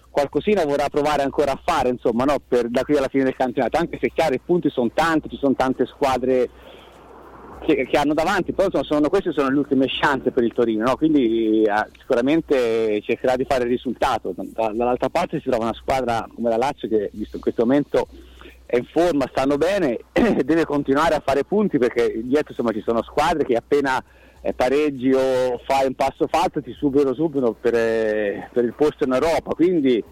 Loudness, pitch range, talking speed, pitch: -21 LUFS, 120-150 Hz, 200 wpm, 135 Hz